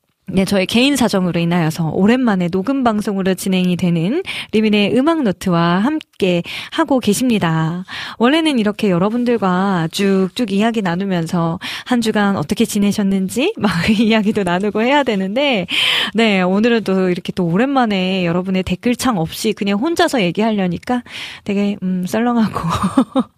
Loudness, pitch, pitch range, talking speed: -16 LUFS, 205 Hz, 185-235 Hz, 330 characters per minute